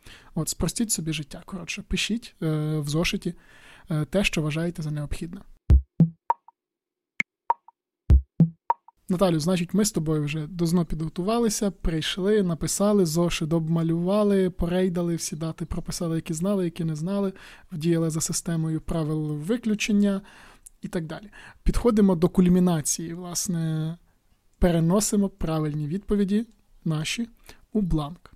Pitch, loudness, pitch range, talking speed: 175 Hz, -25 LUFS, 160-205 Hz, 115 wpm